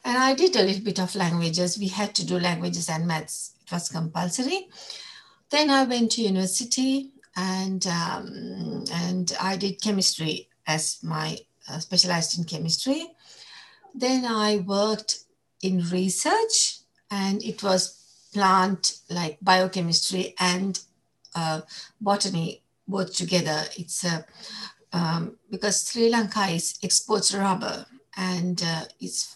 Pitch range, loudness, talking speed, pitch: 175-210 Hz, -25 LUFS, 130 wpm, 190 Hz